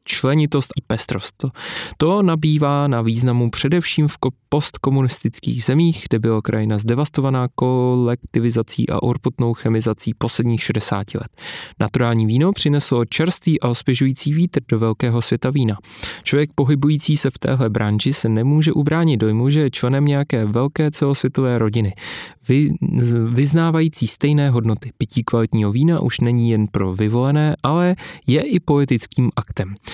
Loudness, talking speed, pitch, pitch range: -18 LUFS, 135 wpm, 130 Hz, 115-145 Hz